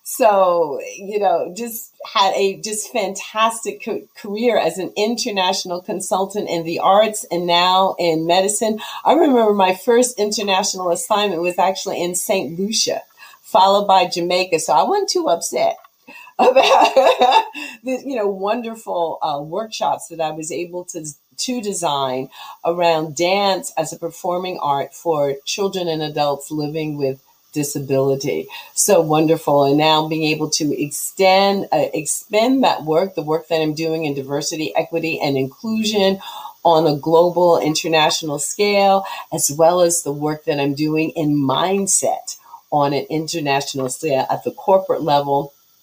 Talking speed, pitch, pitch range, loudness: 145 wpm, 175 Hz, 155-205 Hz, -18 LUFS